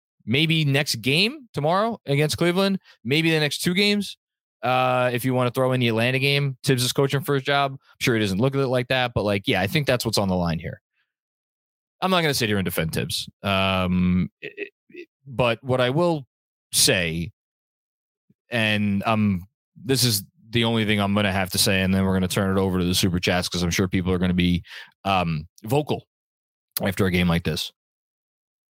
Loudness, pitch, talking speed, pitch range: -22 LUFS, 125 Hz, 215 wpm, 95-140 Hz